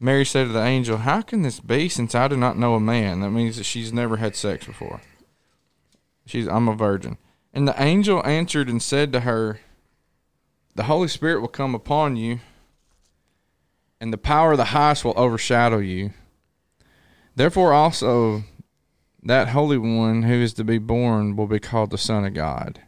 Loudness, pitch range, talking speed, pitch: -21 LUFS, 110-140 Hz, 180 wpm, 120 Hz